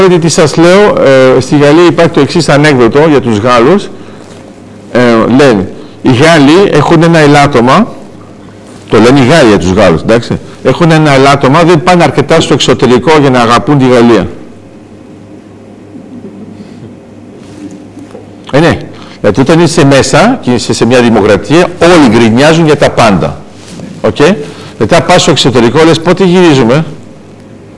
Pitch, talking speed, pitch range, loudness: 135 Hz, 145 wpm, 115-160 Hz, -5 LUFS